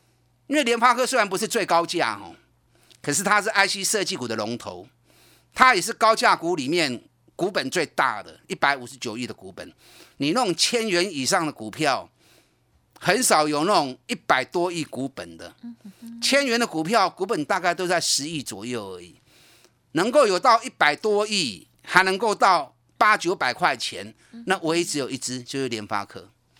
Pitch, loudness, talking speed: 170 Hz, -22 LUFS, 260 characters per minute